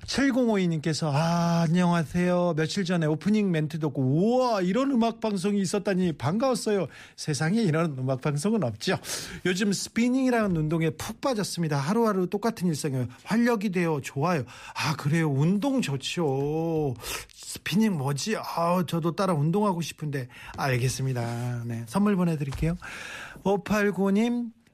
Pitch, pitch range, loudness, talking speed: 175 Hz, 150-205 Hz, -26 LUFS, 315 characters per minute